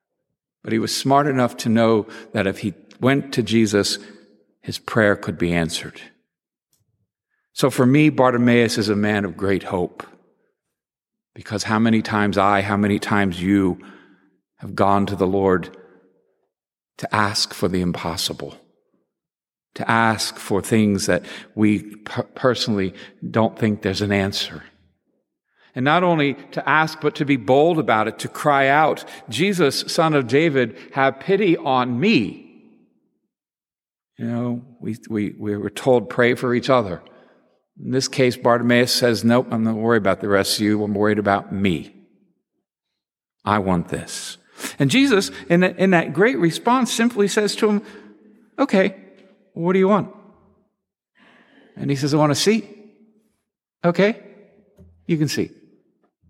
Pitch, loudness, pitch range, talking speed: 120 Hz, -19 LUFS, 105-155 Hz, 150 wpm